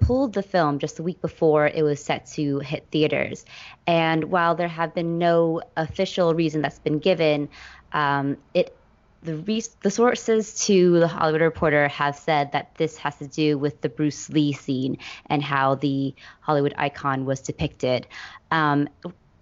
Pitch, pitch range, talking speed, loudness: 155 Hz, 145-170 Hz, 165 wpm, -23 LUFS